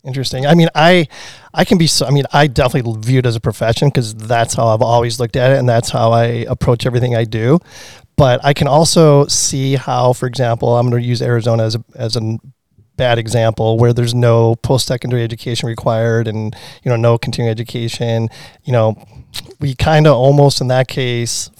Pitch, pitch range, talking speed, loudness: 120 Hz, 115-135 Hz, 205 wpm, -14 LUFS